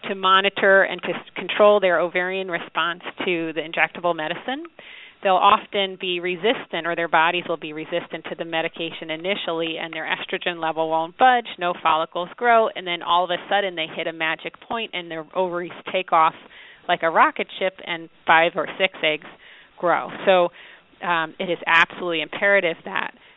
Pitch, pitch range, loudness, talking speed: 175 Hz, 165-190 Hz, -21 LUFS, 175 wpm